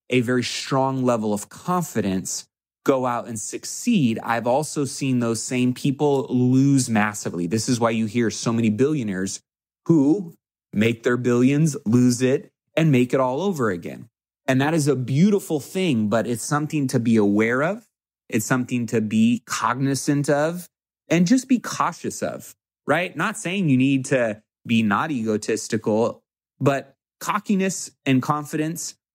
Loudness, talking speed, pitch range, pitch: -22 LUFS, 155 wpm, 115-150 Hz, 130 Hz